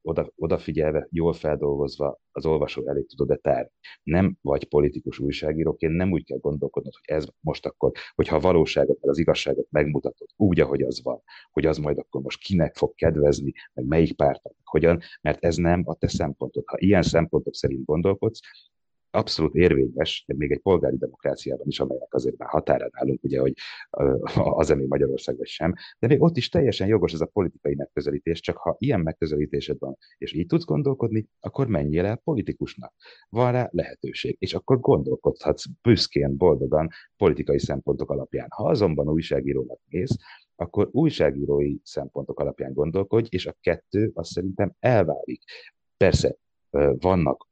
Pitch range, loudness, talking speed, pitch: 75-105 Hz, -24 LUFS, 155 wpm, 85 Hz